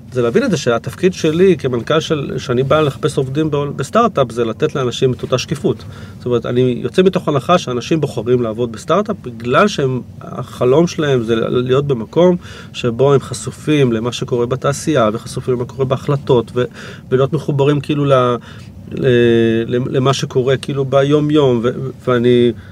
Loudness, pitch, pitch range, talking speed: -15 LUFS, 130 Hz, 120-150 Hz, 145 wpm